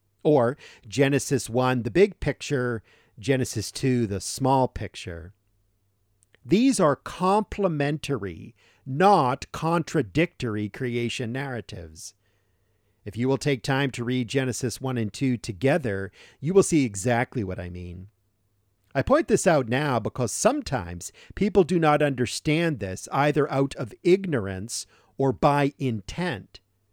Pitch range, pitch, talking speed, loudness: 105-145 Hz, 125 Hz, 125 wpm, -25 LUFS